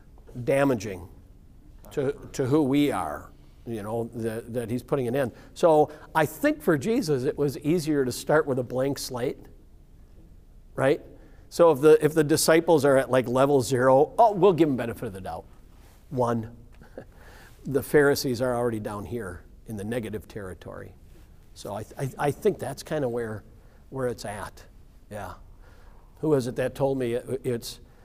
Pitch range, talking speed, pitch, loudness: 105-140 Hz, 170 wpm, 120 Hz, -25 LUFS